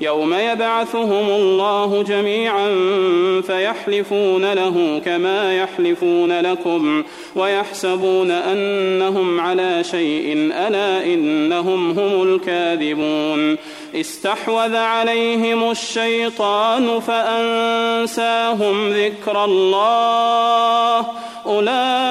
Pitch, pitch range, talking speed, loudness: 205 Hz, 185-230 Hz, 65 wpm, -17 LUFS